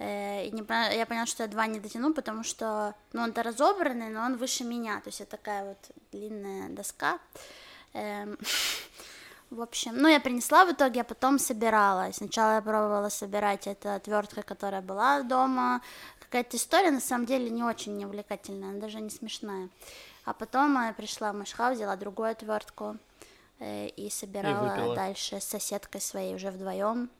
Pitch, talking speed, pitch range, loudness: 215 Hz, 160 wpm, 205-245 Hz, -30 LUFS